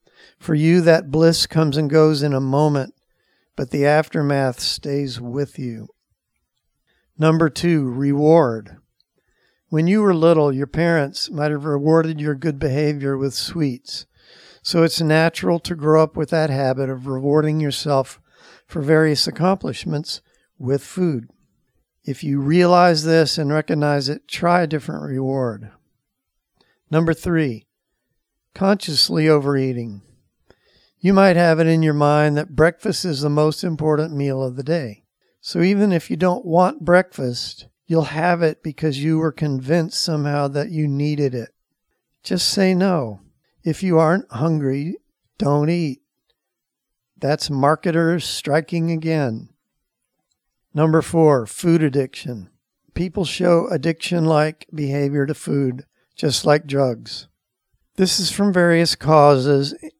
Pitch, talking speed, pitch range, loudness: 155 Hz, 135 wpm, 140-165 Hz, -19 LUFS